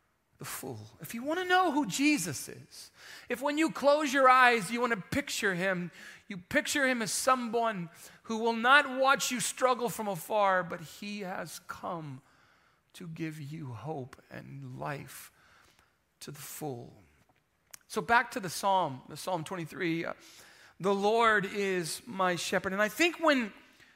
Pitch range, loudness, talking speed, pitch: 175-255 Hz, -29 LUFS, 165 wpm, 210 Hz